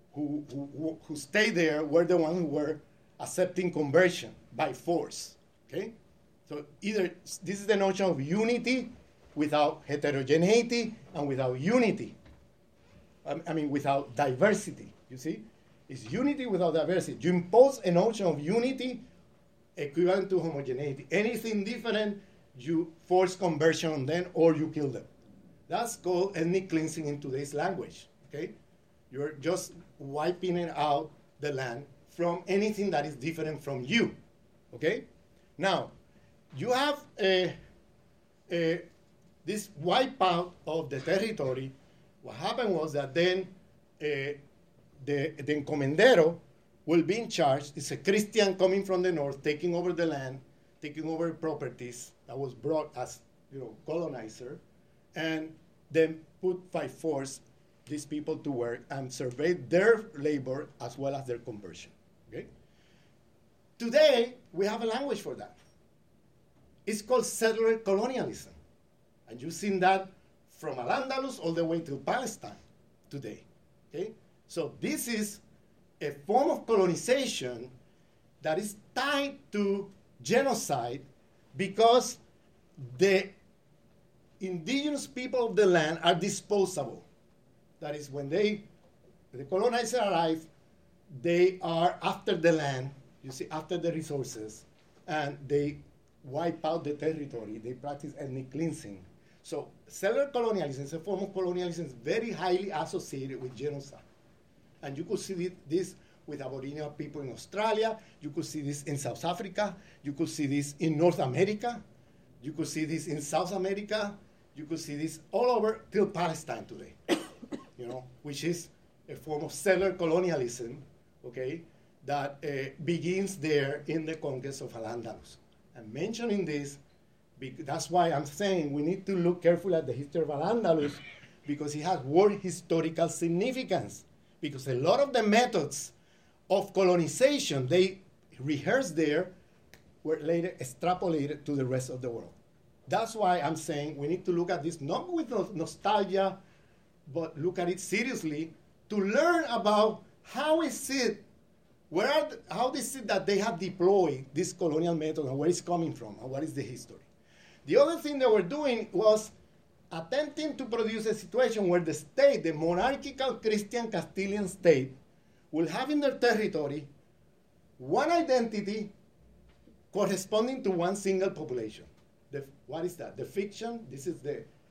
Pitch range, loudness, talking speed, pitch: 145-195 Hz, -30 LUFS, 145 wpm, 170 Hz